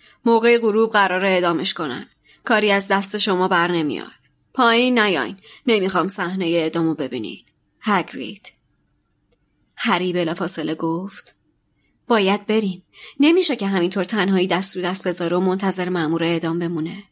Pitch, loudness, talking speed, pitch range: 185 Hz, -18 LUFS, 130 wpm, 175-210 Hz